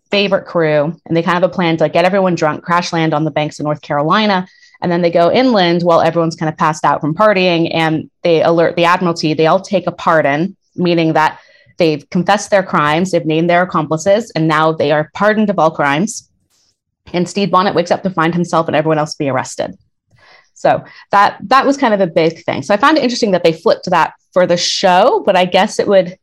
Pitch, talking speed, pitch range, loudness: 170 Hz, 235 wpm, 155-190 Hz, -13 LUFS